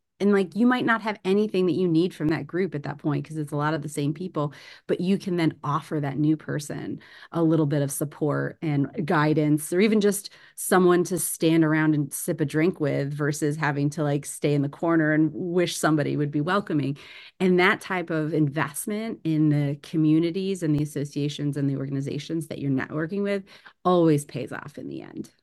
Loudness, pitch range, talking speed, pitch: -25 LUFS, 145-180 Hz, 210 wpm, 155 Hz